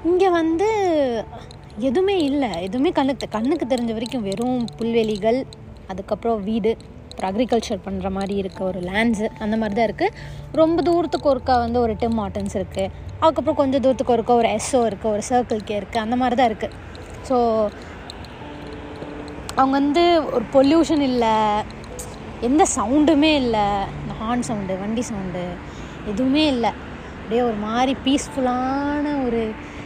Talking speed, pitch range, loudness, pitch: 135 wpm, 215-280 Hz, -21 LUFS, 240 Hz